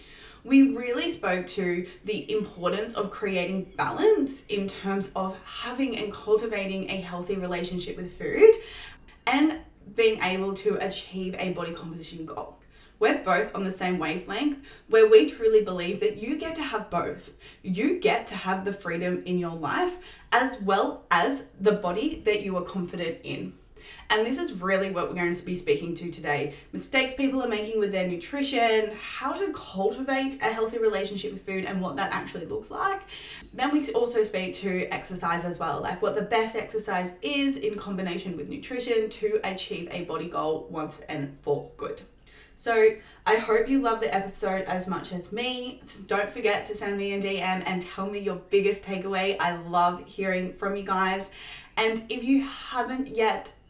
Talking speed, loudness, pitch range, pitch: 180 wpm, -27 LUFS, 185-235 Hz, 200 Hz